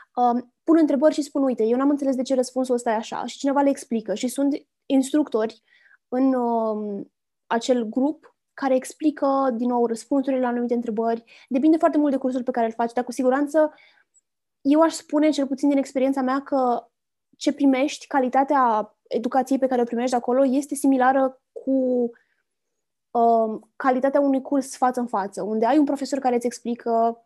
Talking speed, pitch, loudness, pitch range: 175 wpm, 260 Hz, -22 LUFS, 240-280 Hz